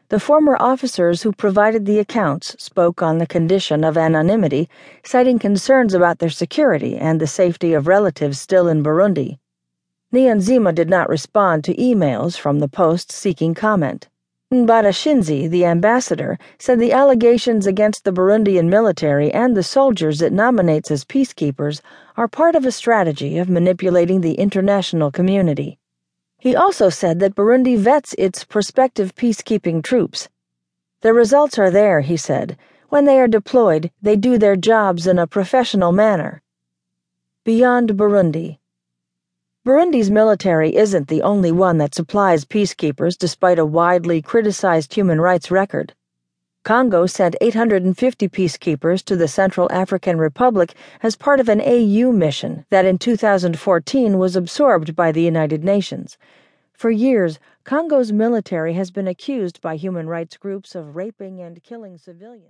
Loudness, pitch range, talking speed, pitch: -16 LUFS, 165-225 Hz, 145 wpm, 185 Hz